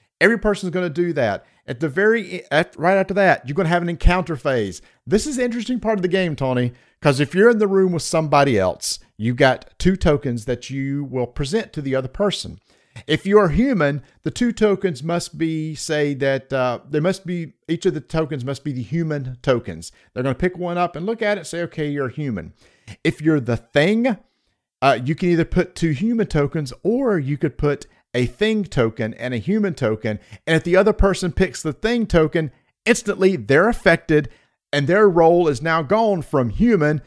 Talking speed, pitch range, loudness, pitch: 210 wpm, 140-190 Hz, -20 LUFS, 160 Hz